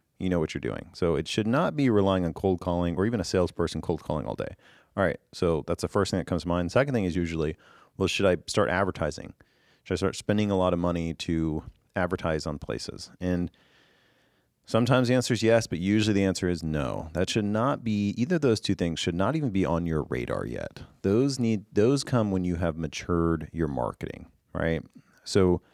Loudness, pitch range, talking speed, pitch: -27 LUFS, 85-105 Hz, 220 wpm, 90 Hz